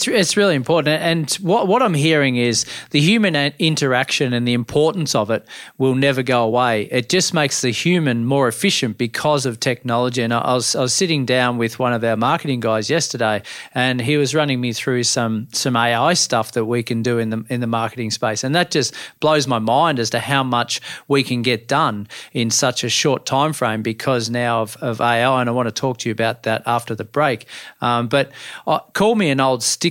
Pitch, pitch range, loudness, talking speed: 125 Hz, 120-150 Hz, -18 LUFS, 215 wpm